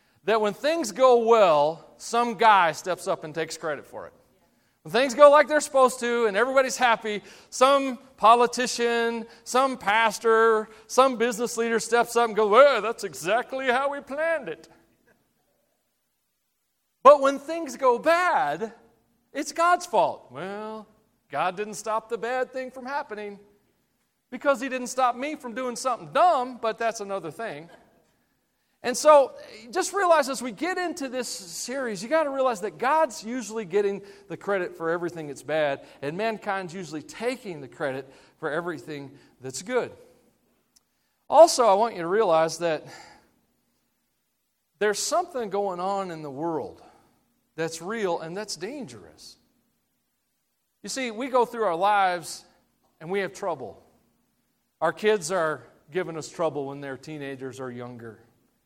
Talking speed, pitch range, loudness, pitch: 150 wpm, 180-255 Hz, -24 LUFS, 225 Hz